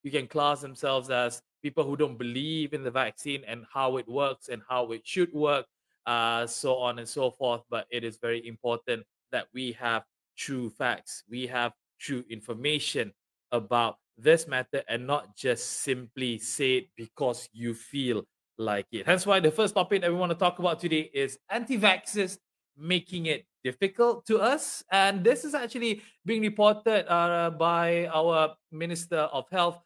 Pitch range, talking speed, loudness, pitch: 120-175 Hz, 175 wpm, -28 LUFS, 140 Hz